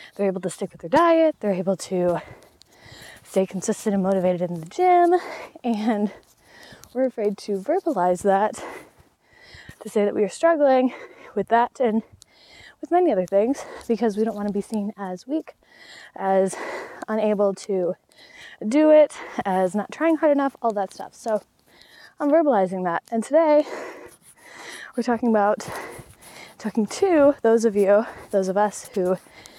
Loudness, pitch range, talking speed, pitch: -22 LUFS, 195-285 Hz, 155 wpm, 215 Hz